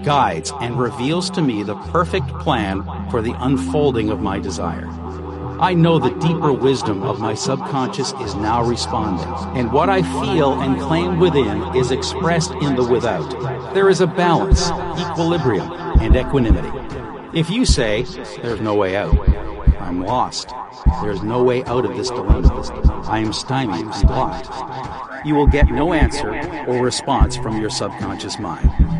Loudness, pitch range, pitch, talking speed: -19 LUFS, 95-150 Hz, 125 Hz, 160 wpm